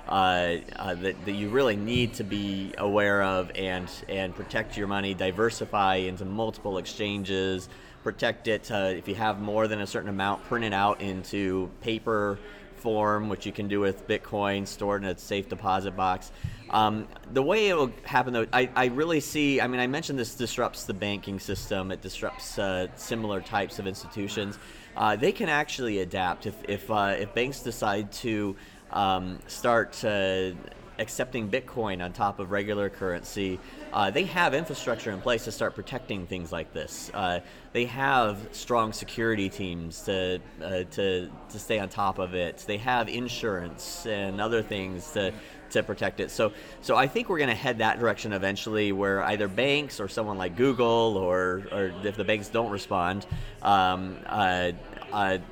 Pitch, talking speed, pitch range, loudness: 100 Hz, 175 wpm, 95-110 Hz, -28 LUFS